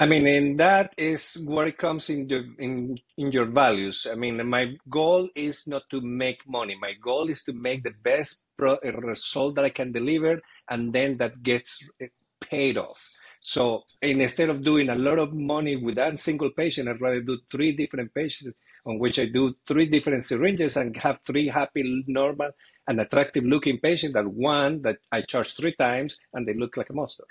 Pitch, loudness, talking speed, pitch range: 140 Hz, -25 LUFS, 195 wpm, 125-150 Hz